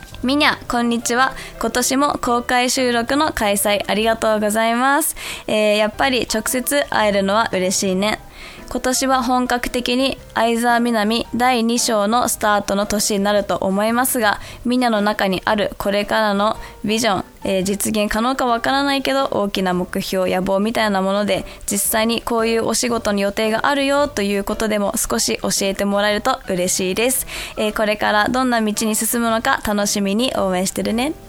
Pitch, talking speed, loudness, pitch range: 220 Hz, 355 characters per minute, -18 LUFS, 205-245 Hz